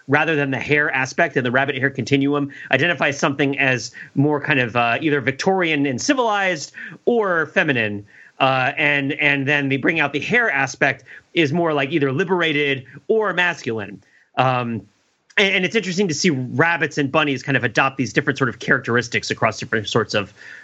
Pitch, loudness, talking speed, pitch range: 140 Hz, -19 LUFS, 180 wpm, 130-160 Hz